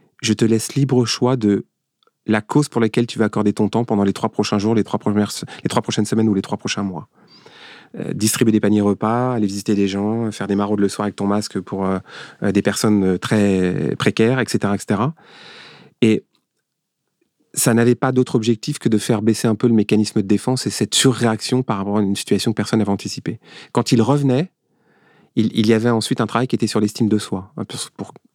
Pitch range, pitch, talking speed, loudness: 105-120 Hz, 110 Hz, 220 wpm, -19 LUFS